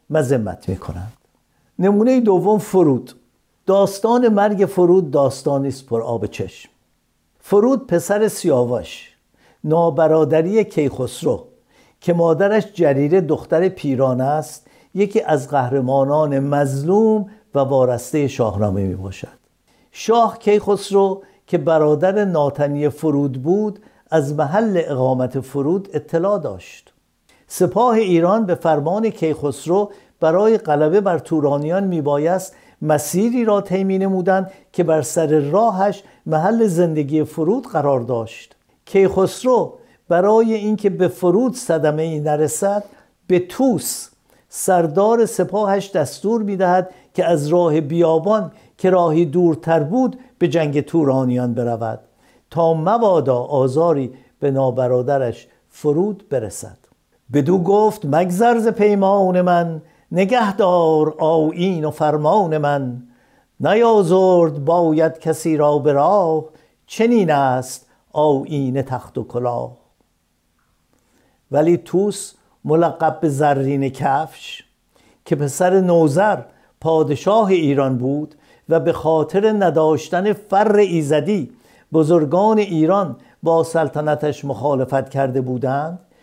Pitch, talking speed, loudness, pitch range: 165 Hz, 105 wpm, -17 LUFS, 145-195 Hz